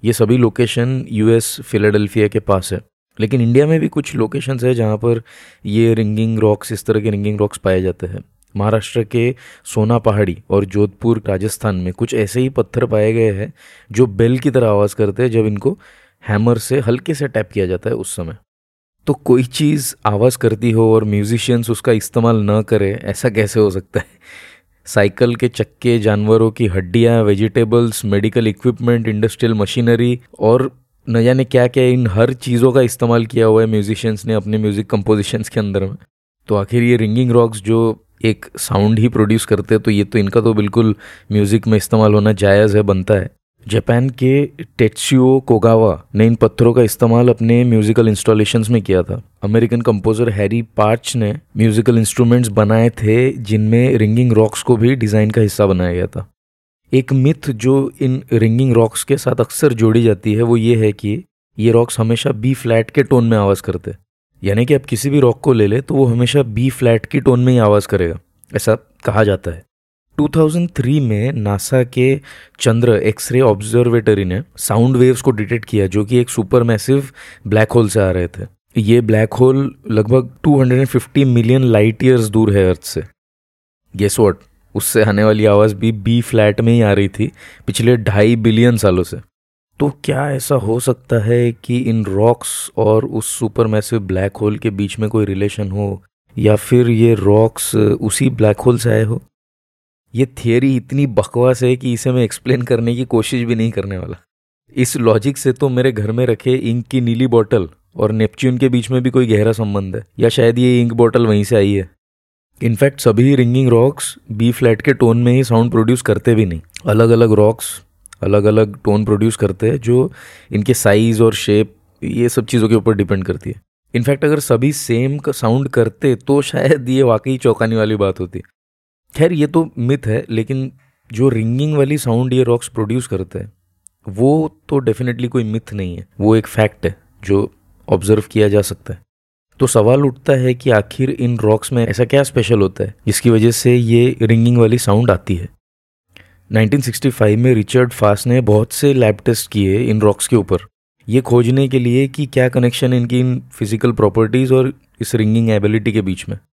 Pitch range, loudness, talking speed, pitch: 105-125 Hz, -14 LUFS, 190 wpm, 115 Hz